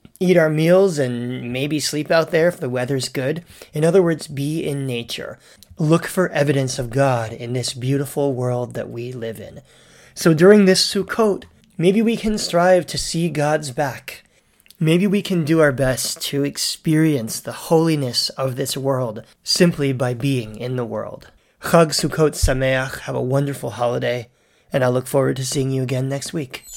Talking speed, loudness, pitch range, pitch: 175 wpm, -19 LUFS, 125-165 Hz, 140 Hz